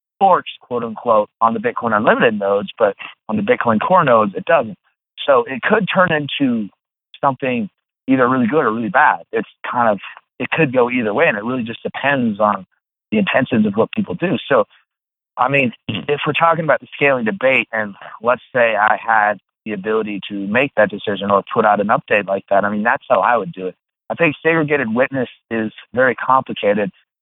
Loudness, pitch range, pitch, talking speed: -17 LUFS, 100-155 Hz, 115 Hz, 200 wpm